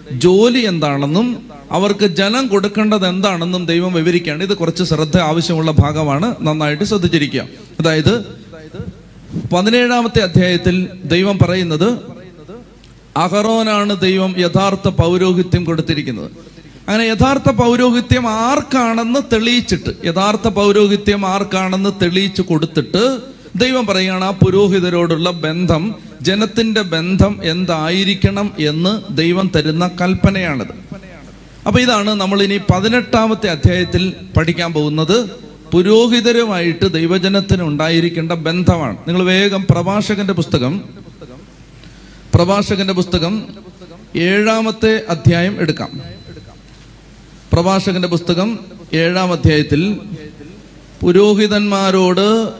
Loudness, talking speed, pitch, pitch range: -14 LUFS, 85 wpm, 185 Hz, 170-210 Hz